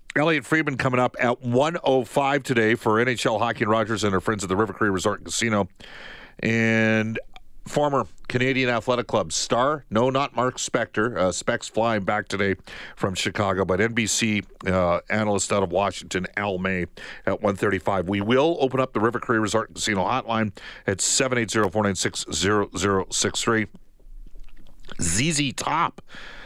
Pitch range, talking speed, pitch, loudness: 100-125 Hz, 150 wpm, 110 Hz, -23 LUFS